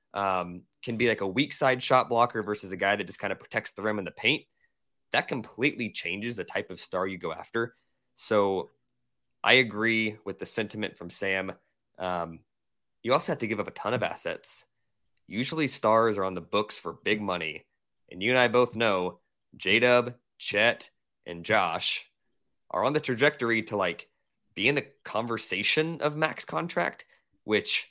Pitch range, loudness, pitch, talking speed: 95-125 Hz, -28 LUFS, 110 Hz, 185 wpm